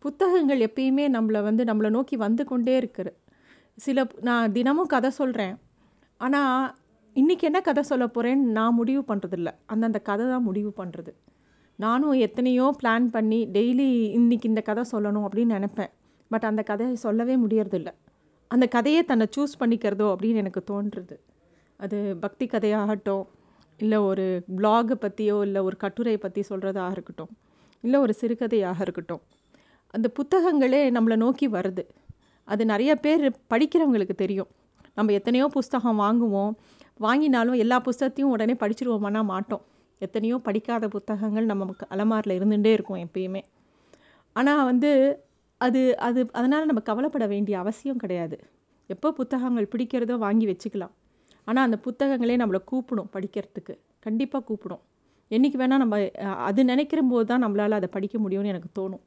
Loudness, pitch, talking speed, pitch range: -25 LUFS, 225 Hz, 135 wpm, 205-255 Hz